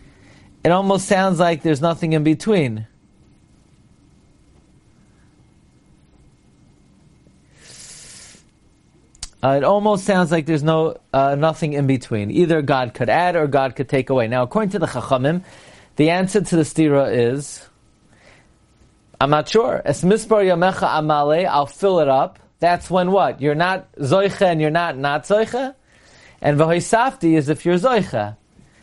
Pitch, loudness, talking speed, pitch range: 160 Hz, -18 LUFS, 145 wpm, 140-185 Hz